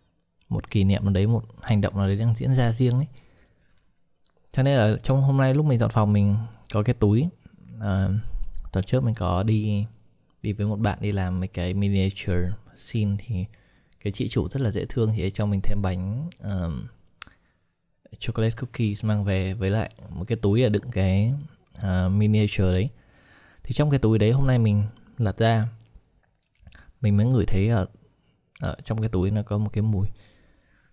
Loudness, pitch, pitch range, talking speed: -25 LUFS, 105 Hz, 100-115 Hz, 185 wpm